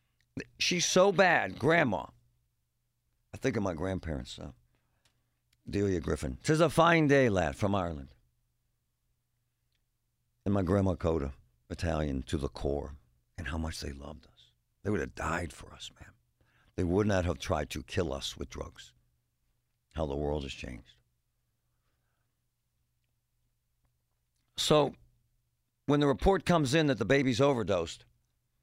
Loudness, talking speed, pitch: -30 LUFS, 135 wpm, 80 Hz